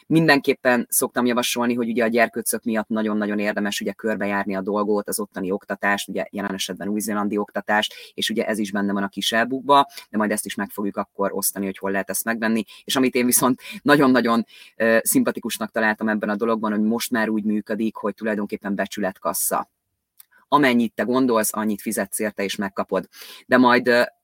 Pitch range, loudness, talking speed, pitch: 100-120 Hz, -22 LUFS, 180 wpm, 110 Hz